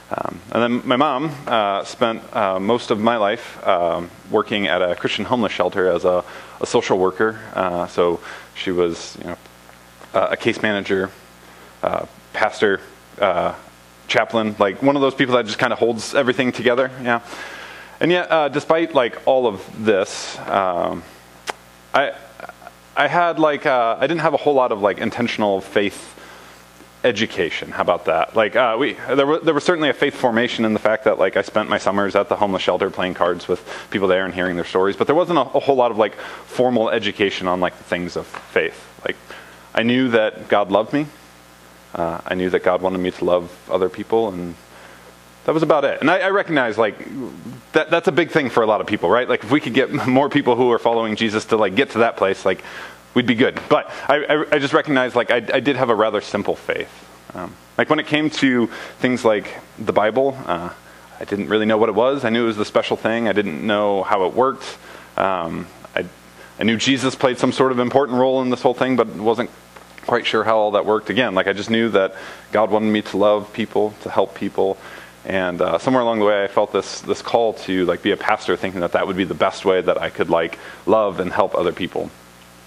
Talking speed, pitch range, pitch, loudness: 225 wpm, 85-125 Hz, 105 Hz, -19 LUFS